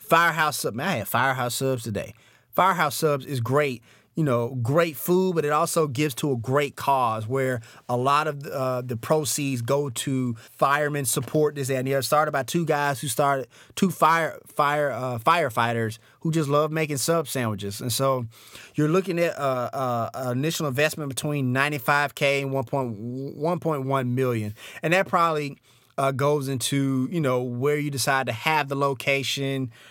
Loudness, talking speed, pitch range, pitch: -24 LUFS, 185 wpm, 125-150 Hz, 140 Hz